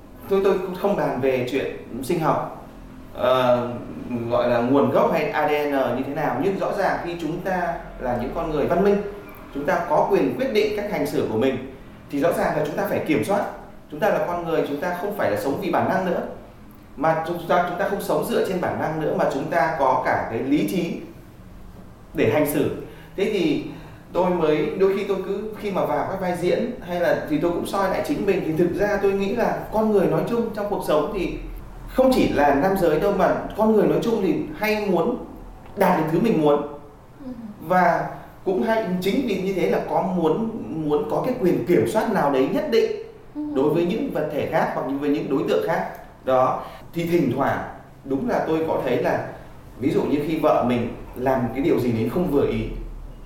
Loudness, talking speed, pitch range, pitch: -22 LUFS, 225 wpm, 145-200 Hz, 170 Hz